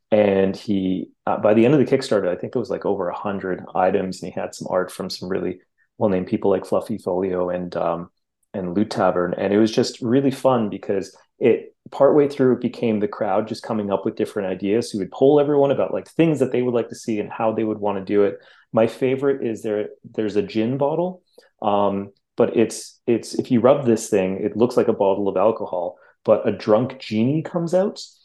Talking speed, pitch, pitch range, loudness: 225 wpm, 110 Hz, 100-130 Hz, -21 LUFS